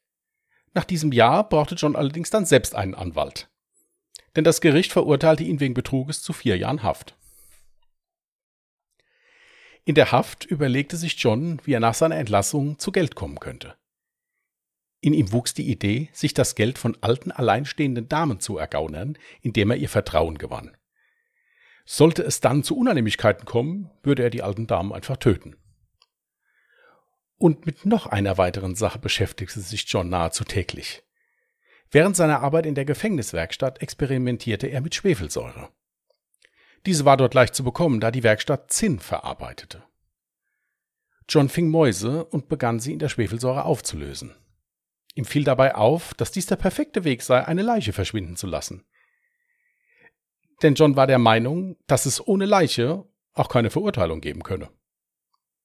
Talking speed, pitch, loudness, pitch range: 150 wpm, 145 Hz, -22 LUFS, 115-175 Hz